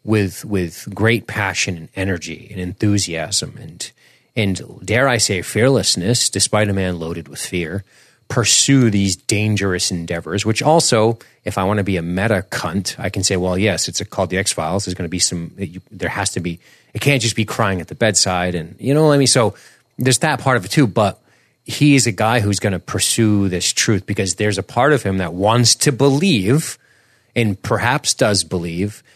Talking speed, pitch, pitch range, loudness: 205 wpm, 105 Hz, 95-120 Hz, -17 LUFS